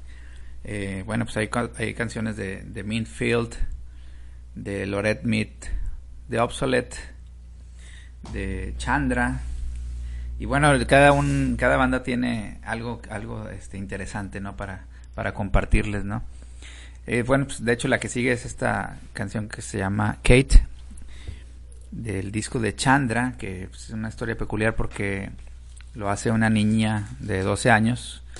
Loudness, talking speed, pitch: -25 LUFS, 135 wpm, 100 Hz